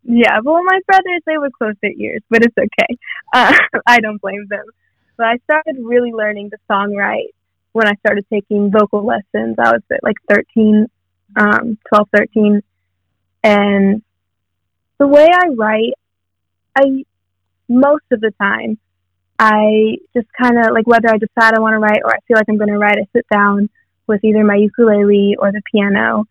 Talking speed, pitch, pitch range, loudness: 180 wpm, 215 Hz, 200-235 Hz, -13 LUFS